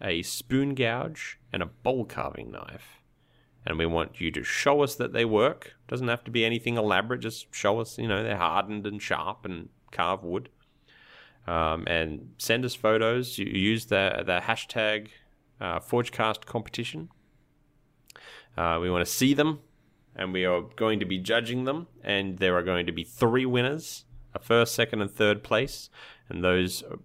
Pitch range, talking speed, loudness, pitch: 95-125 Hz, 175 wpm, -27 LUFS, 110 Hz